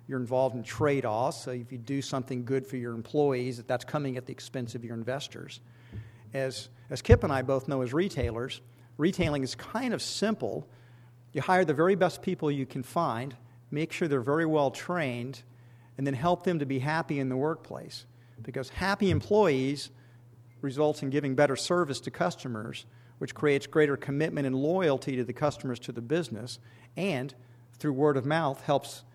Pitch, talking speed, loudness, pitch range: 135 Hz, 185 wpm, -30 LUFS, 120-150 Hz